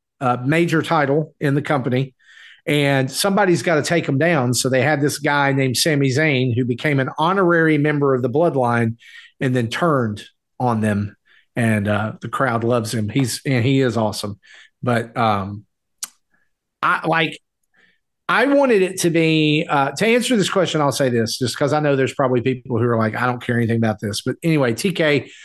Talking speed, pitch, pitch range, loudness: 195 wpm, 135 Hz, 120-155 Hz, -18 LUFS